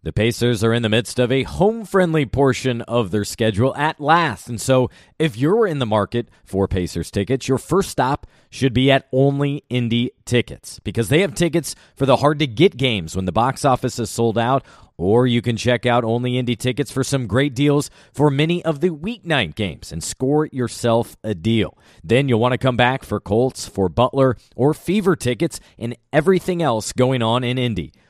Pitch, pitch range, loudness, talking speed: 125 Hz, 115-145 Hz, -19 LUFS, 205 wpm